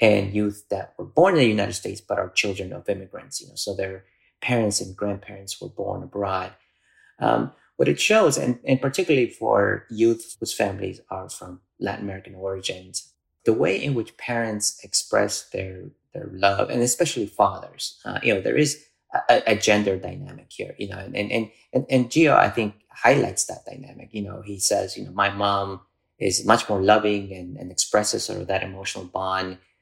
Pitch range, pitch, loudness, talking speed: 95-110 Hz, 100 Hz, -23 LUFS, 190 wpm